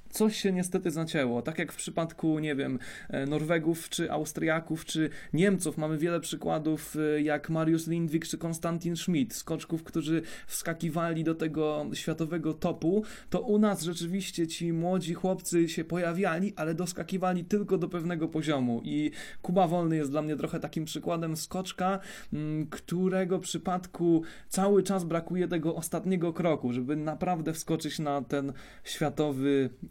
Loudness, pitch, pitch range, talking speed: -31 LUFS, 165 Hz, 155-180 Hz, 140 wpm